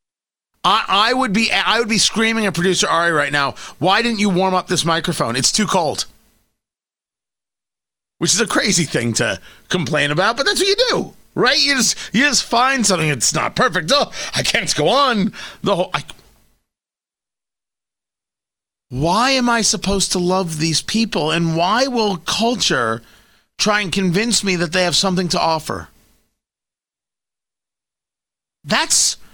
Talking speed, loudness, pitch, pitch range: 155 wpm, -16 LUFS, 190 Hz, 170-225 Hz